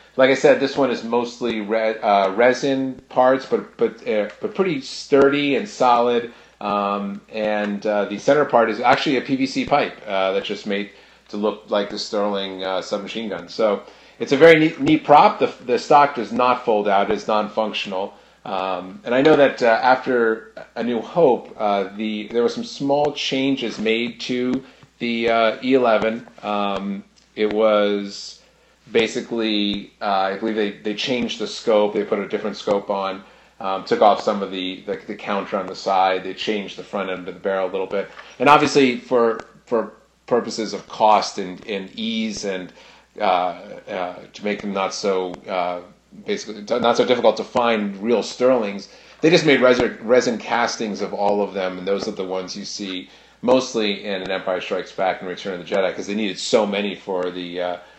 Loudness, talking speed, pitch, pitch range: -20 LUFS, 190 wpm, 105 Hz, 100-125 Hz